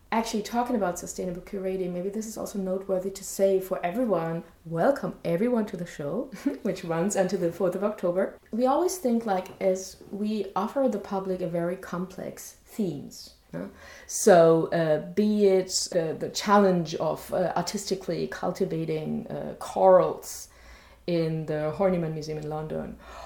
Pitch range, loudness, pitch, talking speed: 170-205 Hz, -27 LUFS, 185 Hz, 150 wpm